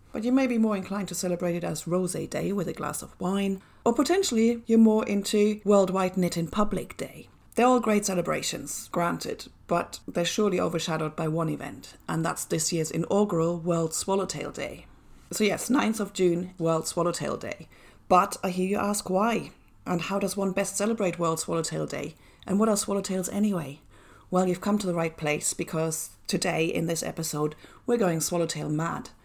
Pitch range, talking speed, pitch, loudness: 165-205 Hz, 185 wpm, 185 Hz, -27 LUFS